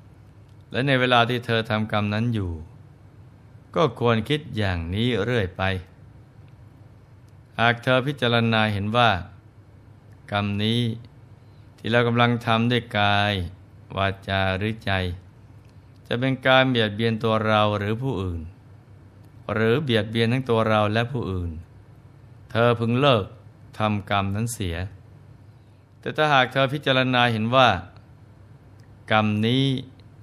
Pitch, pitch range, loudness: 110 Hz, 105-120 Hz, -22 LUFS